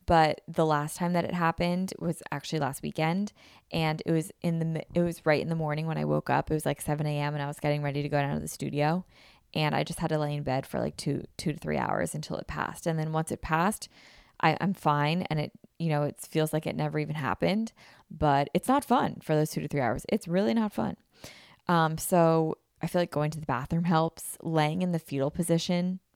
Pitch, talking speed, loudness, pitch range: 160 Hz, 245 wpm, -29 LUFS, 150-175 Hz